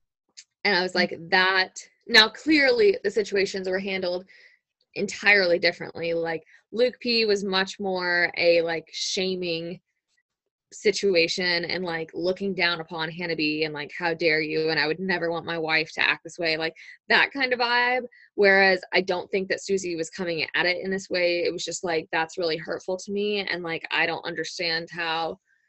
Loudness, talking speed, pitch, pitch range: -24 LUFS, 185 wpm, 175 Hz, 165-195 Hz